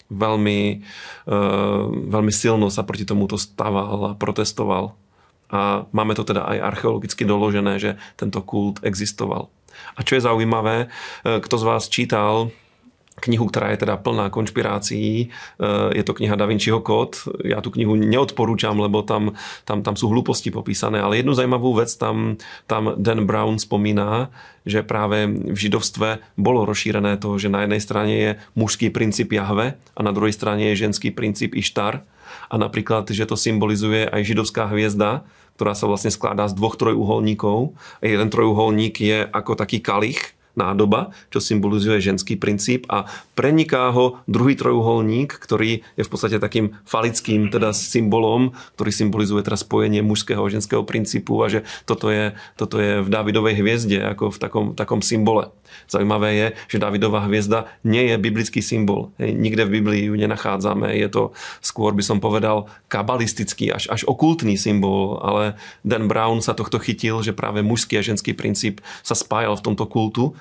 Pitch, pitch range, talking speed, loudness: 105 Hz, 105-115 Hz, 160 wpm, -20 LUFS